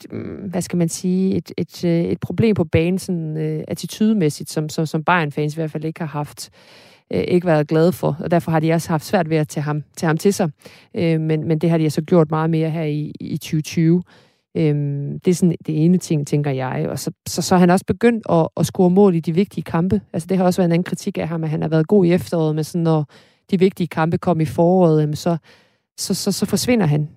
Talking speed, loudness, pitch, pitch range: 255 wpm, -19 LUFS, 165 Hz, 155-180 Hz